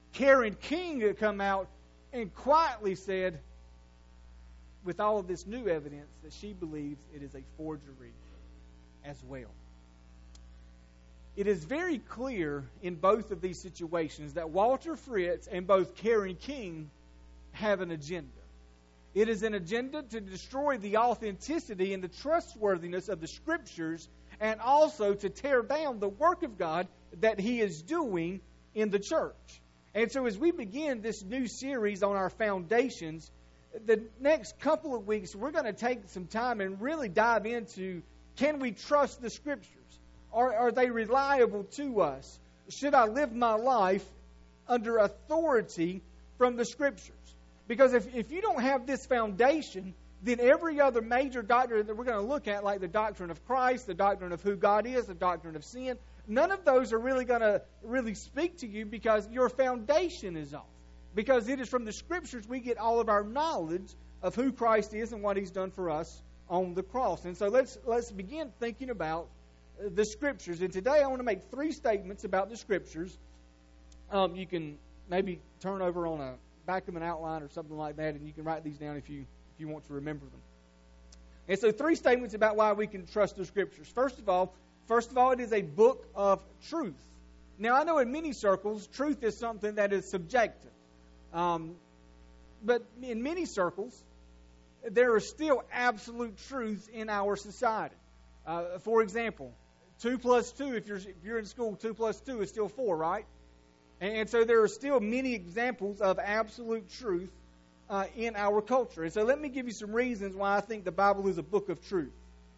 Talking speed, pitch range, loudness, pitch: 185 wpm, 160-245 Hz, -31 LUFS, 205 Hz